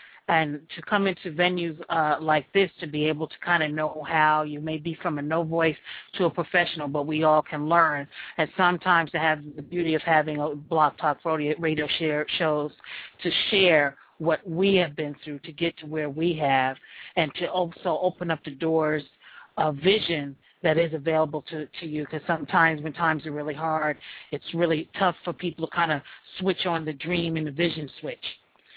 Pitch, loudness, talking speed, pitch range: 160 Hz, -25 LUFS, 200 wpm, 150-170 Hz